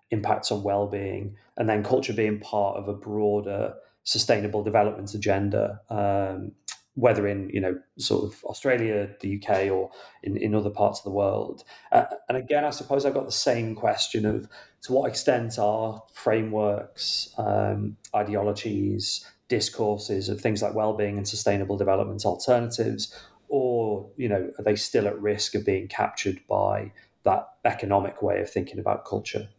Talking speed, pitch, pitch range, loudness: 160 wpm, 105 Hz, 100-110 Hz, -26 LUFS